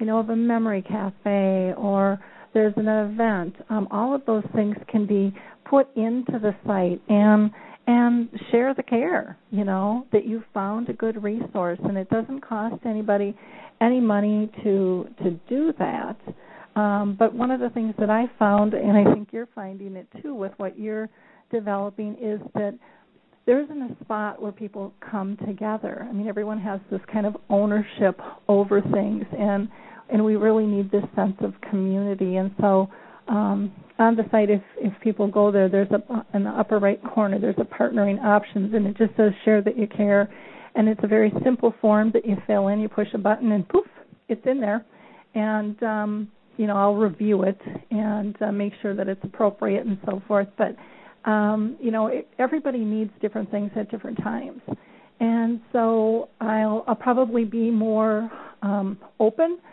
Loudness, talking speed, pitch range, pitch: -23 LUFS, 180 wpm, 205-225 Hz, 215 Hz